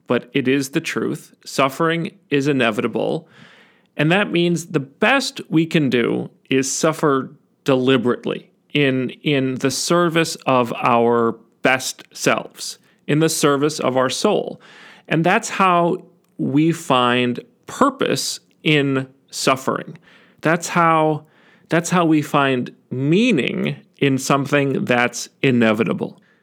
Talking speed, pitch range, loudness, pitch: 120 wpm, 130-170 Hz, -19 LUFS, 150 Hz